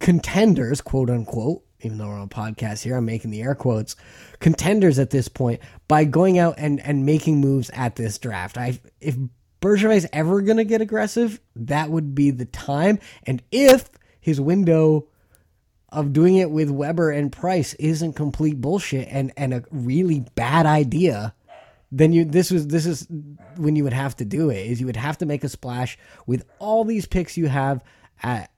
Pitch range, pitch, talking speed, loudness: 125-165 Hz, 145 Hz, 190 wpm, -21 LUFS